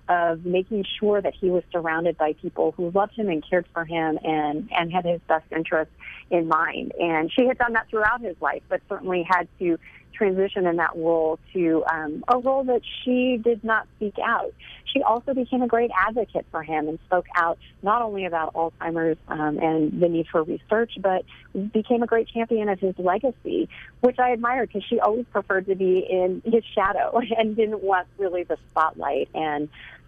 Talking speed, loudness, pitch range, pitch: 195 wpm, -24 LUFS, 165-225 Hz, 185 Hz